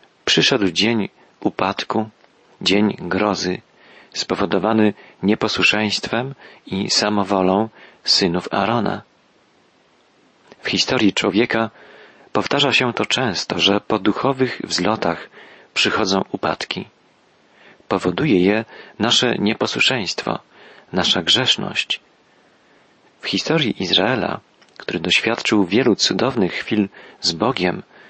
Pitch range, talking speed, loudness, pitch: 100-115 Hz, 85 wpm, -18 LUFS, 105 Hz